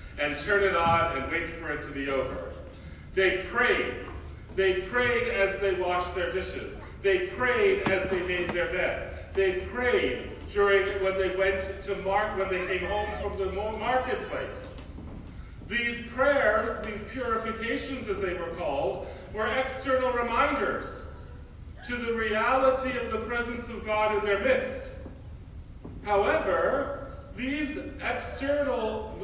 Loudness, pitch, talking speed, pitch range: -28 LUFS, 200 Hz, 140 wpm, 180-240 Hz